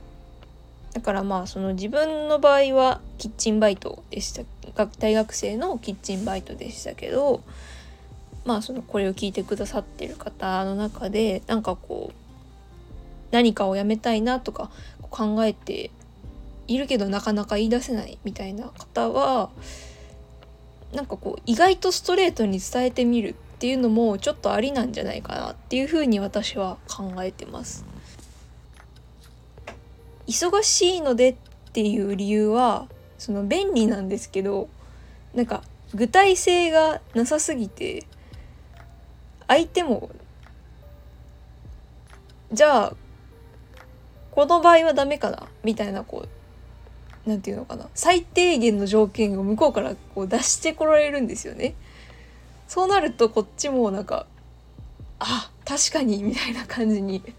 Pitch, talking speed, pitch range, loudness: 215 Hz, 250 characters per minute, 185-255 Hz, -23 LUFS